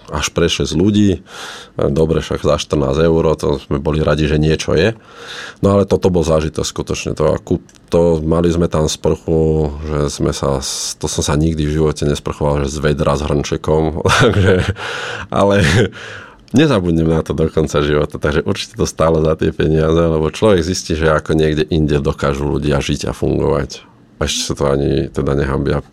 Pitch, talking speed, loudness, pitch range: 80 Hz, 175 wpm, -15 LUFS, 75-80 Hz